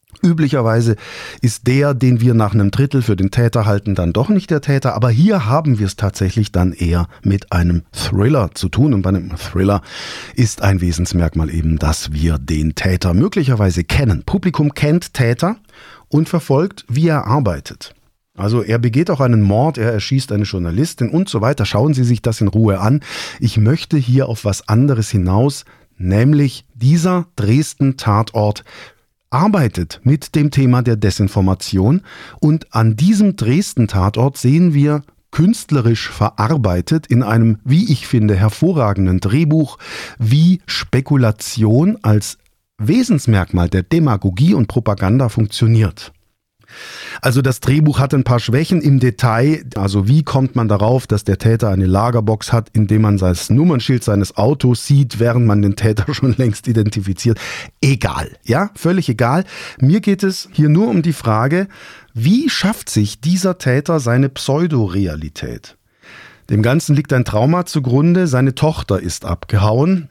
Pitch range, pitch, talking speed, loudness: 105-145 Hz, 120 Hz, 150 wpm, -15 LUFS